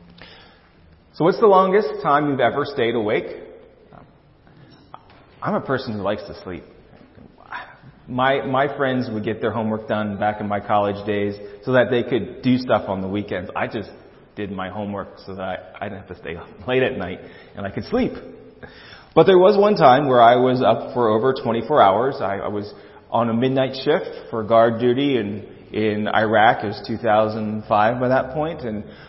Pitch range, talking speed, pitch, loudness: 105-135 Hz, 190 wpm, 115 Hz, -20 LUFS